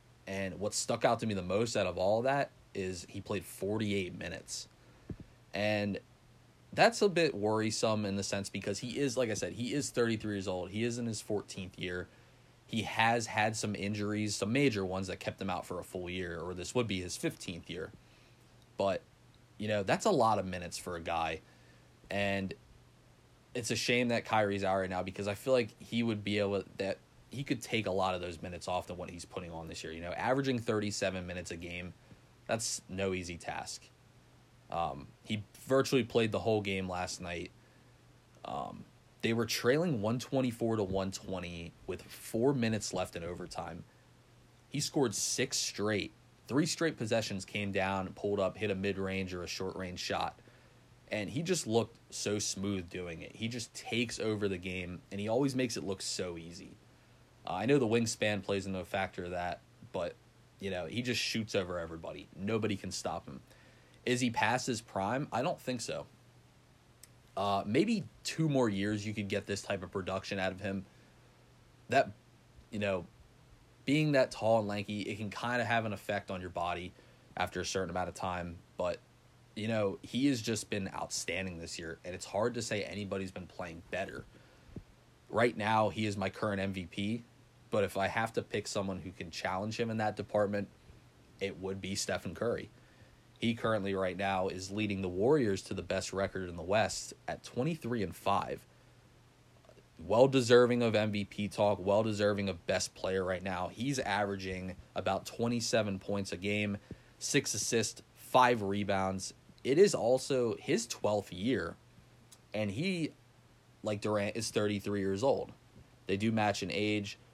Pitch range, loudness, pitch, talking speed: 95-120 Hz, -34 LUFS, 105 Hz, 185 wpm